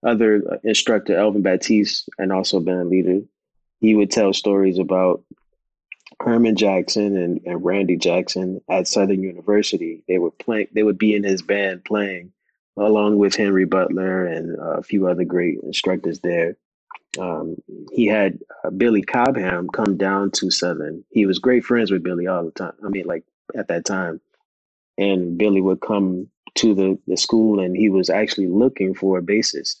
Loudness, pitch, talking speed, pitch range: -19 LUFS, 95 Hz, 170 wpm, 95-105 Hz